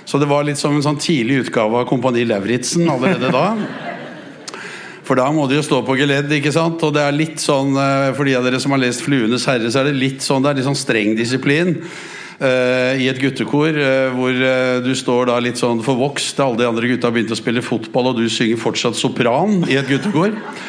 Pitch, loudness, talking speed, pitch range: 135 Hz, -16 LUFS, 210 wpm, 125-145 Hz